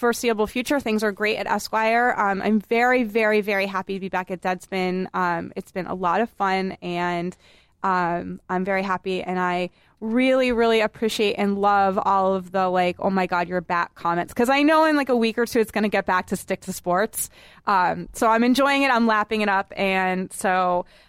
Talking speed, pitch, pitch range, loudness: 215 wpm, 195 Hz, 185-225 Hz, -22 LUFS